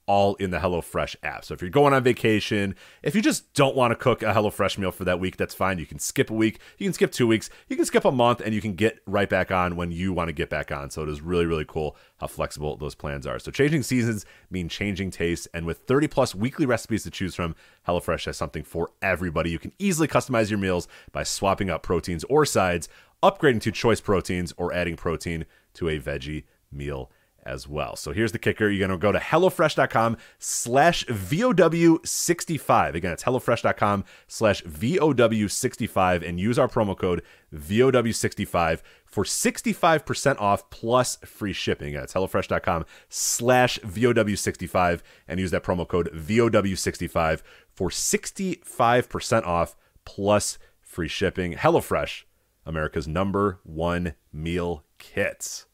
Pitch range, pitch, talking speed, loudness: 85-120 Hz, 100 Hz, 175 wpm, -24 LUFS